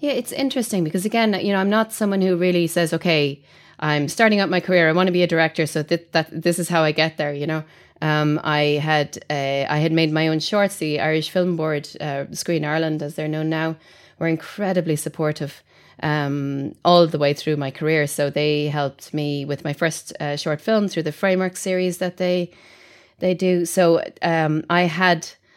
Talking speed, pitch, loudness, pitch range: 210 wpm, 160 Hz, -21 LUFS, 150-180 Hz